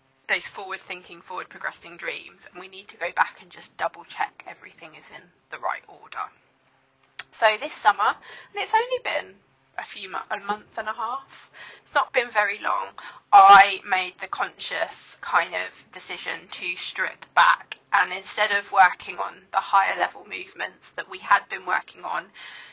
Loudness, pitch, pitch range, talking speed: -23 LUFS, 205 Hz, 195-250 Hz, 175 wpm